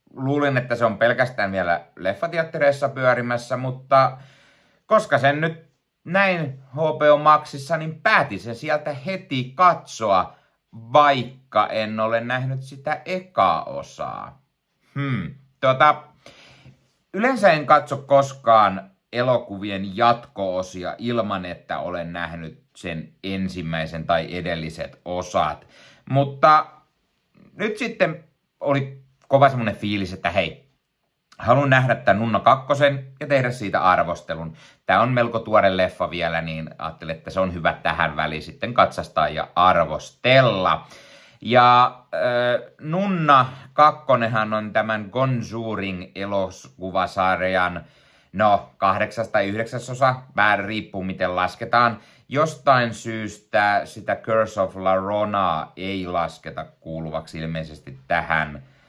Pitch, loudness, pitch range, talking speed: 120 Hz, -21 LUFS, 95-140 Hz, 110 wpm